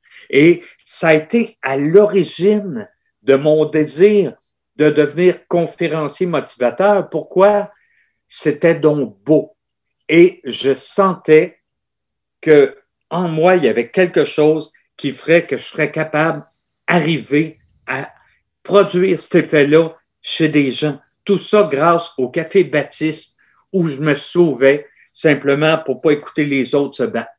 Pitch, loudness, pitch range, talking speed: 160 Hz, -15 LUFS, 150-190 Hz, 130 wpm